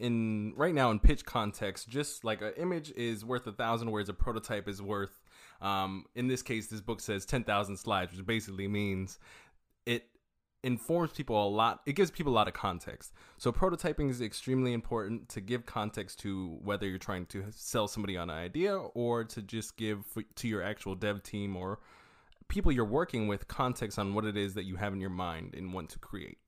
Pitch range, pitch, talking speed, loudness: 100-120 Hz, 105 Hz, 205 wpm, -35 LUFS